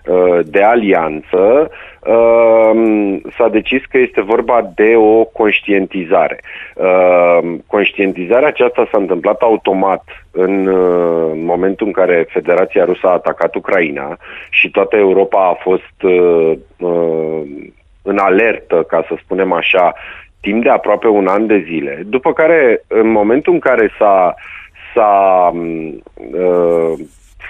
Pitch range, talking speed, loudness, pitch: 85-110 Hz, 110 wpm, -12 LUFS, 90 Hz